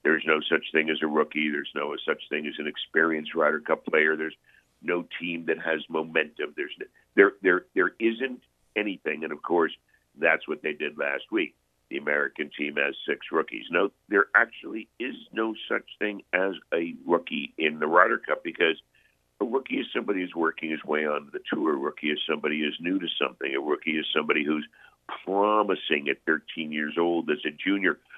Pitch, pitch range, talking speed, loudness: 80 Hz, 75-100 Hz, 200 wpm, -27 LUFS